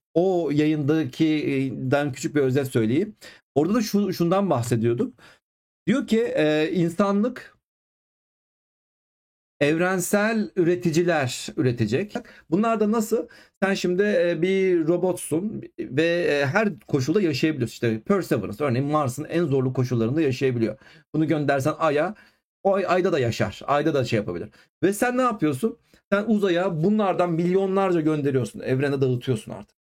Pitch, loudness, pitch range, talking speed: 165 Hz, -23 LUFS, 140-195 Hz, 120 wpm